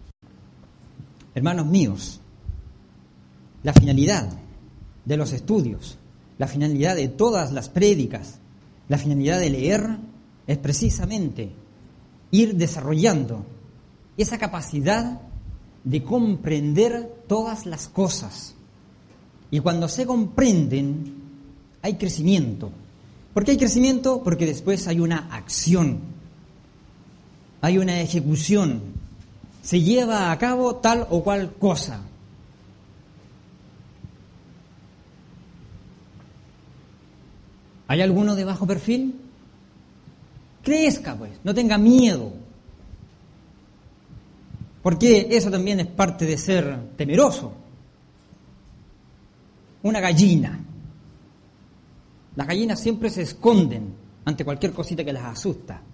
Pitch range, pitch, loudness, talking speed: 135-205 Hz, 165 Hz, -21 LUFS, 90 wpm